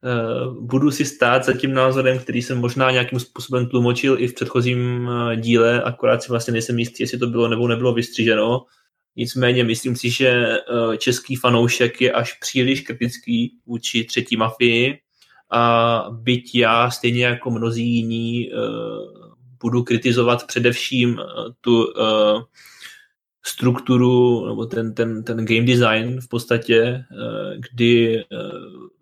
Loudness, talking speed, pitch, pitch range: -19 LUFS, 125 wpm, 120 Hz, 115-125 Hz